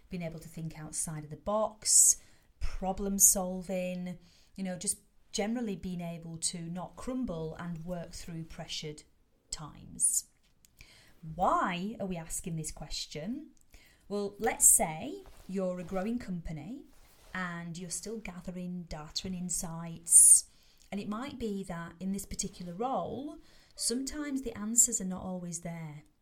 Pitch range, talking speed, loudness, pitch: 165-205 Hz, 135 wpm, -29 LUFS, 185 Hz